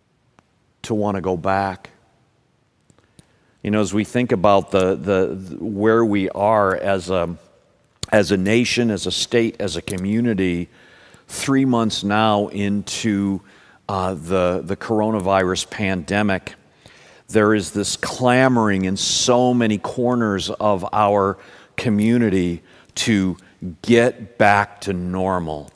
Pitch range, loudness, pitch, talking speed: 95-115 Hz, -19 LUFS, 100 Hz, 125 wpm